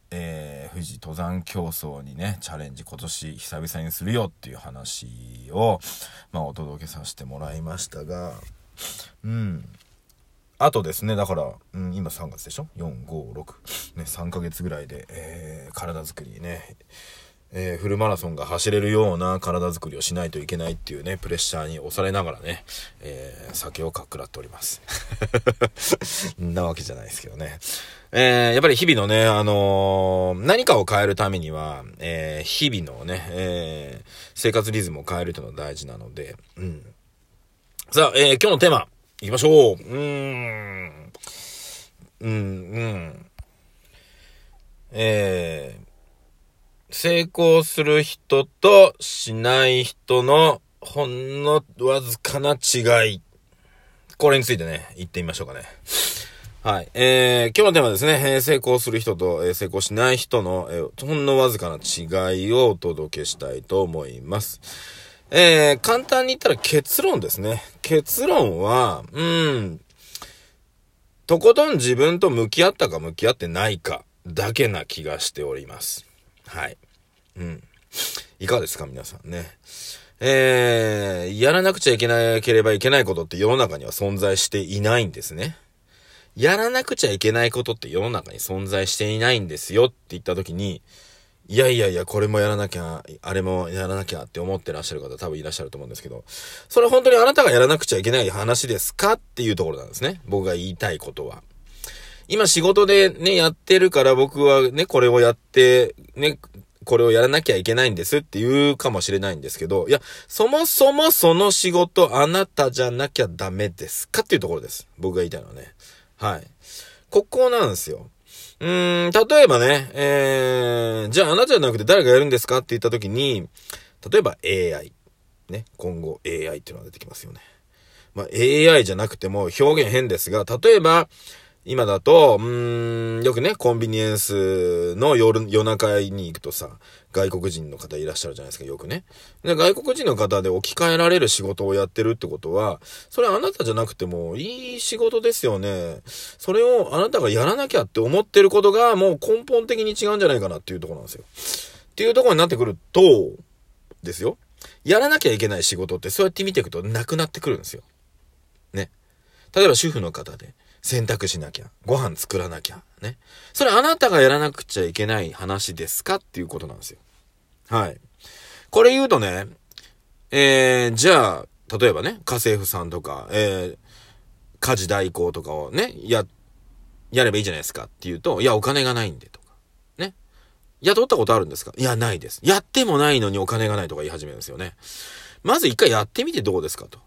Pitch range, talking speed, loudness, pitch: 90-145 Hz, 345 characters per minute, -20 LUFS, 110 Hz